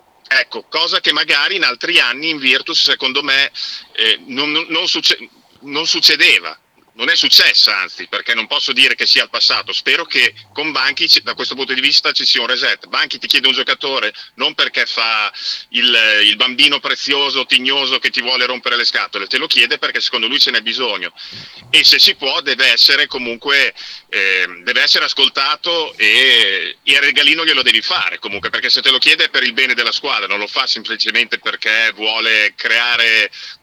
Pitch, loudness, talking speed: 140 Hz, -12 LUFS, 185 wpm